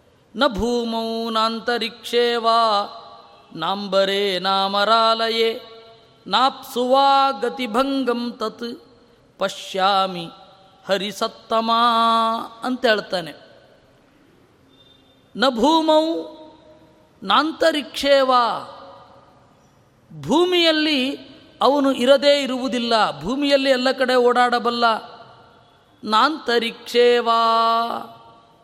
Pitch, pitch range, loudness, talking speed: 235 Hz, 215-265 Hz, -19 LUFS, 50 wpm